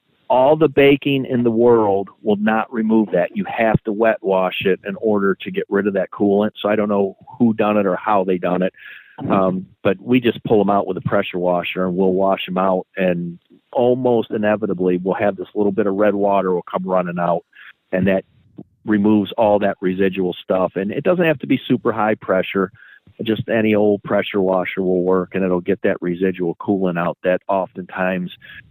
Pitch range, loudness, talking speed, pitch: 95-110 Hz, -18 LUFS, 205 wpm, 100 Hz